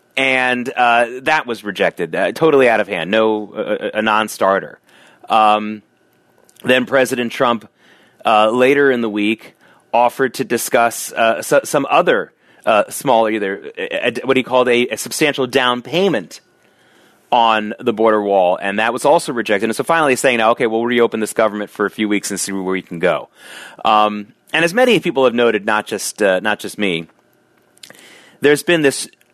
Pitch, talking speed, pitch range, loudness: 115 Hz, 180 wpm, 105-130 Hz, -16 LUFS